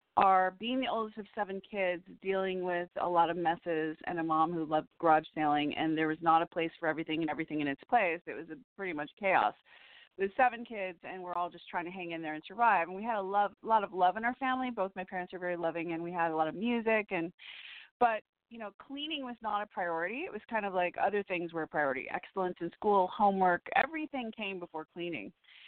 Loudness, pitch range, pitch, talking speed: -33 LUFS, 165-215 Hz, 185 Hz, 245 wpm